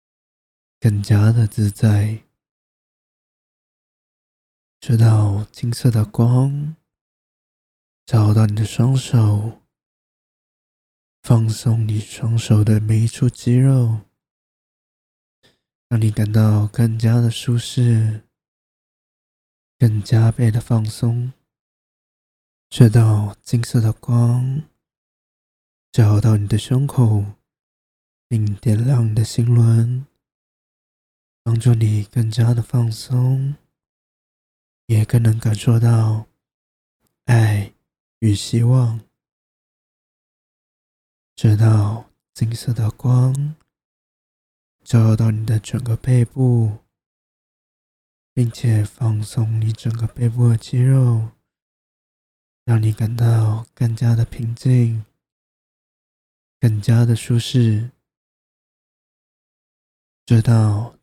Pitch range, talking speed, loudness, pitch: 110-120 Hz, 120 characters per minute, -18 LUFS, 115 Hz